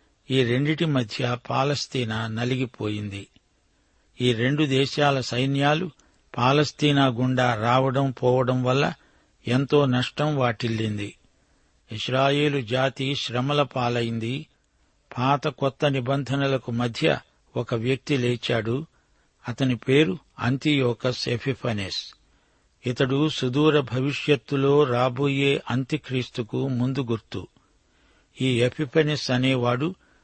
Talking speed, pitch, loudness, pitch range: 85 wpm, 130 Hz, -24 LUFS, 120-140 Hz